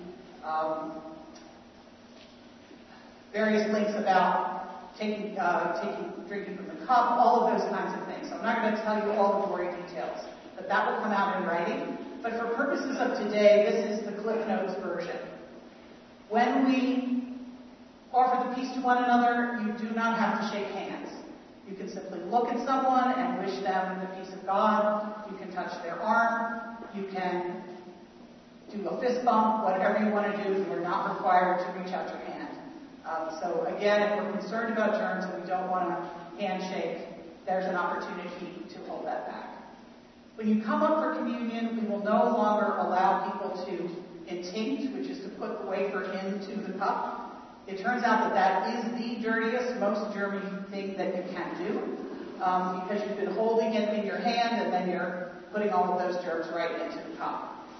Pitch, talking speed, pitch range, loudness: 205 Hz, 185 wpm, 185-230 Hz, -29 LUFS